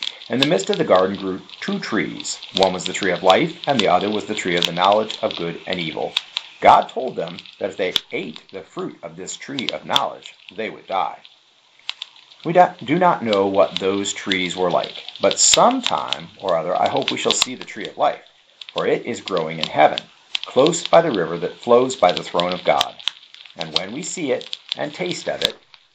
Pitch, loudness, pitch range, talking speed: 95 Hz, -19 LUFS, 90-115 Hz, 215 wpm